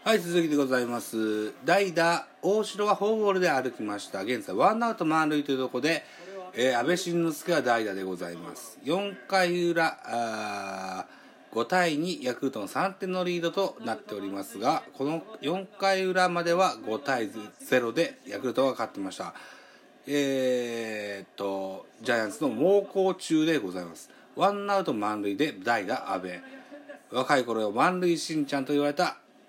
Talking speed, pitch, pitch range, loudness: 305 characters per minute, 160 Hz, 115-185 Hz, -28 LUFS